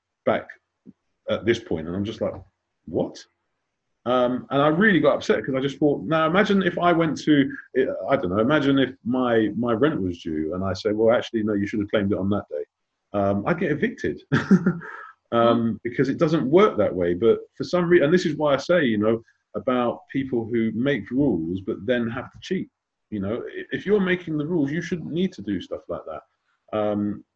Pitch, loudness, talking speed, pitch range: 135 Hz, -23 LUFS, 215 wpm, 110-175 Hz